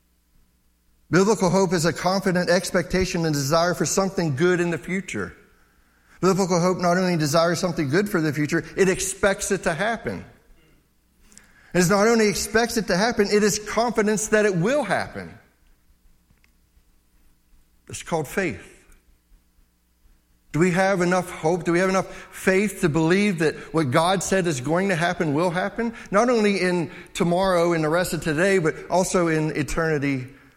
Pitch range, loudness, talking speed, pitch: 145-190 Hz, -22 LUFS, 160 wpm, 175 Hz